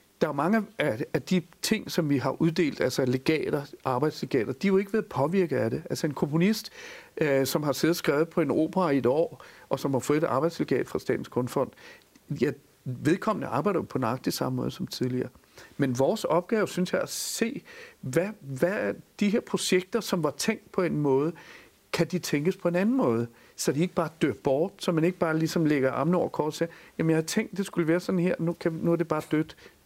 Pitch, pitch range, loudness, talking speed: 170 Hz, 145-185 Hz, -27 LUFS, 230 wpm